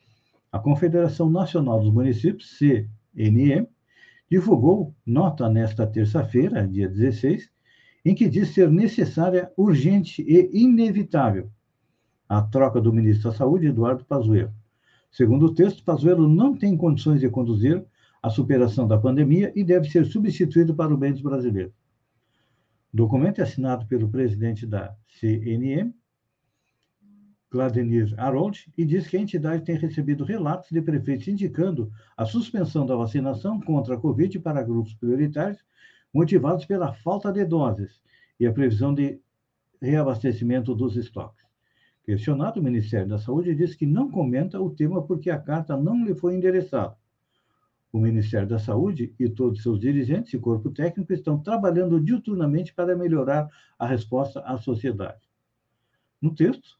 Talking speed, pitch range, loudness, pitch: 140 wpm, 115-175 Hz, -23 LUFS, 140 Hz